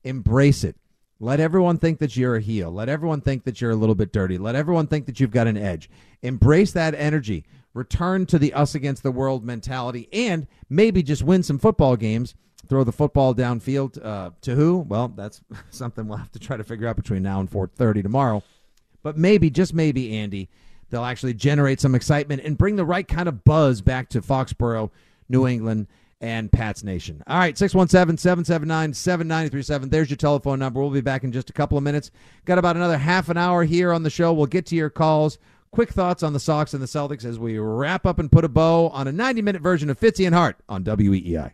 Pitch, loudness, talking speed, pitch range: 140 Hz, -21 LUFS, 220 wpm, 115-165 Hz